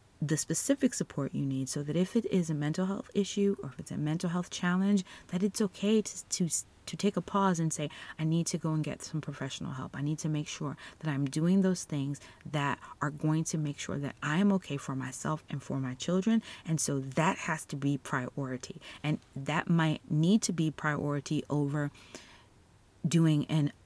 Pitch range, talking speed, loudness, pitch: 140-180 Hz, 210 wpm, -32 LUFS, 155 Hz